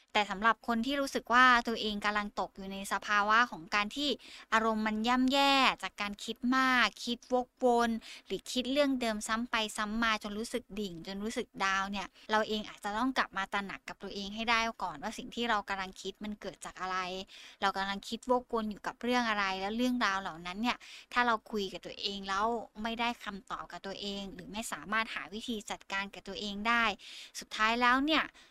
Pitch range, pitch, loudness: 195-240 Hz, 215 Hz, -32 LUFS